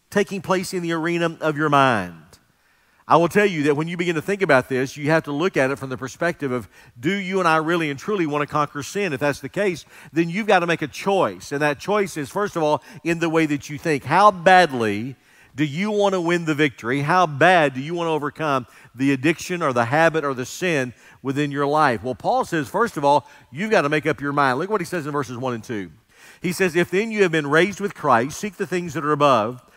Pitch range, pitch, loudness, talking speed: 140-180 Hz, 155 Hz, -21 LUFS, 260 wpm